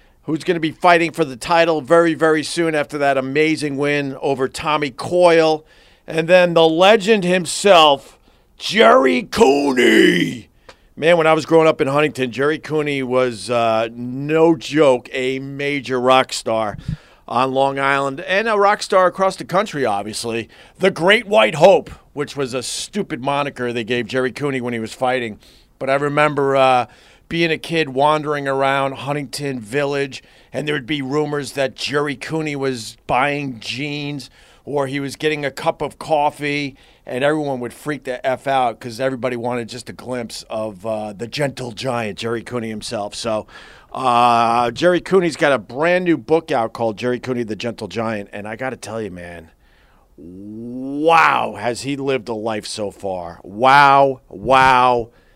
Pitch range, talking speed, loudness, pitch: 120-155 Hz, 170 wpm, -17 LUFS, 135 Hz